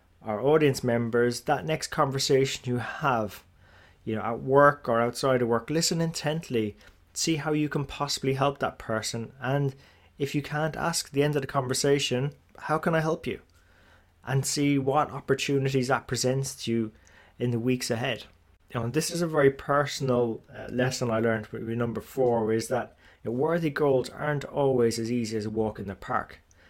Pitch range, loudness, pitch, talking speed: 115-145 Hz, -27 LUFS, 130 Hz, 190 wpm